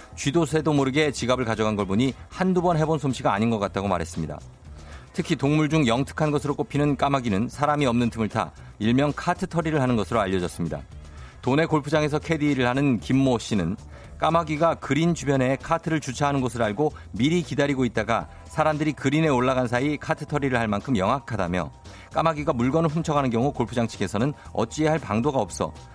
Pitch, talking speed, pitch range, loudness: 135 Hz, 410 characters per minute, 110-155 Hz, -24 LUFS